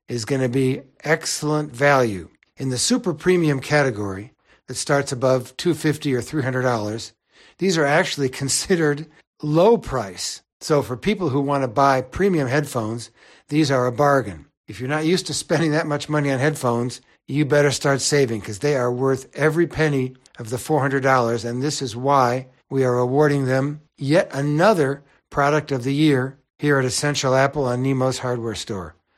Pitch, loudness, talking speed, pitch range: 140 Hz, -21 LUFS, 175 wpm, 125-150 Hz